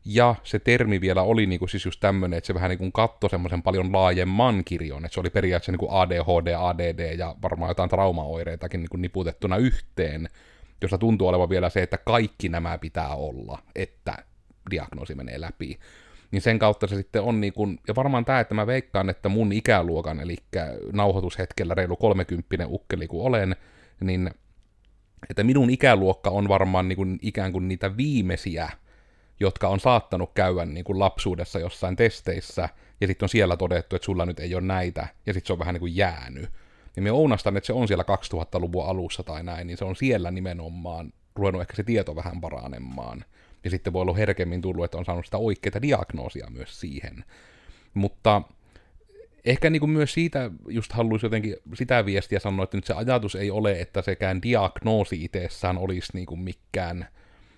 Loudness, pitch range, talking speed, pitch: -25 LUFS, 90-105 Hz, 180 wpm, 95 Hz